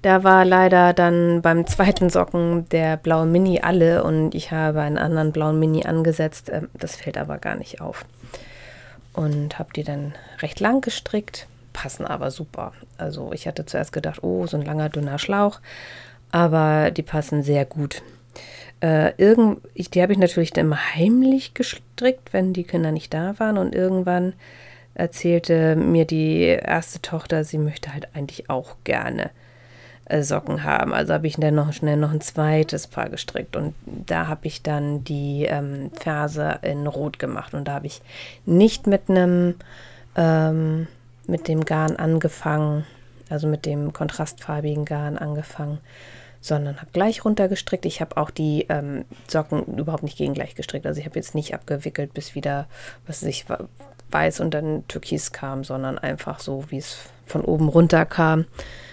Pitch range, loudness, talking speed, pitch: 145-170 Hz, -22 LUFS, 165 wpm, 155 Hz